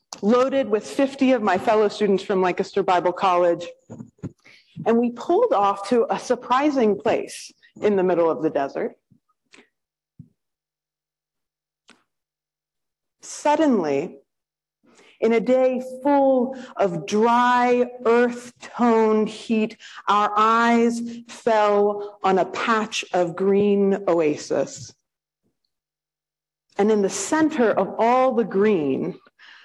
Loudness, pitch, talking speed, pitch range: -21 LUFS, 220 Hz, 105 wpm, 195-245 Hz